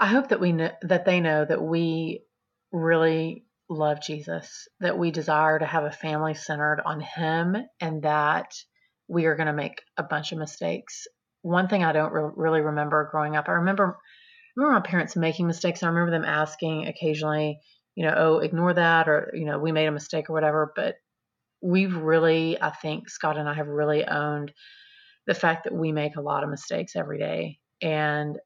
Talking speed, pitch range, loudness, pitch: 200 wpm, 150-175 Hz, -25 LUFS, 160 Hz